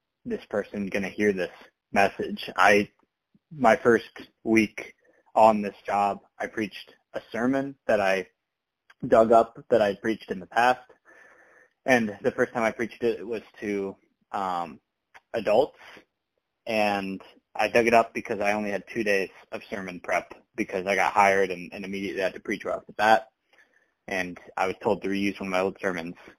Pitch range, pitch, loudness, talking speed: 95-110 Hz, 100 Hz, -26 LUFS, 175 wpm